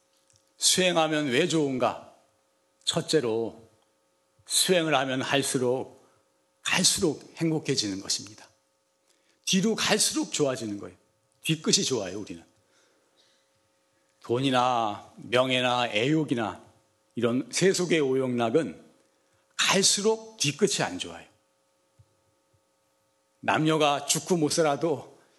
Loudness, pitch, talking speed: -25 LUFS, 130 Hz, 215 characters per minute